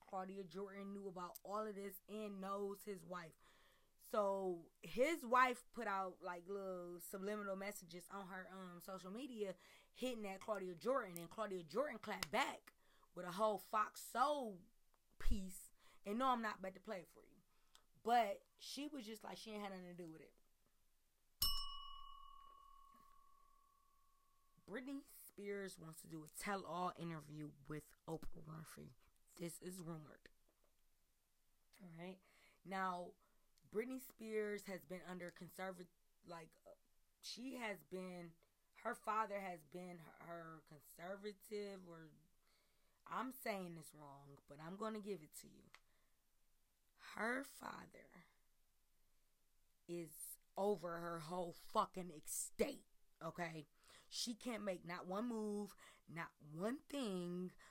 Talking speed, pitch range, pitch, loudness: 130 wpm, 175-220 Hz, 190 Hz, -47 LUFS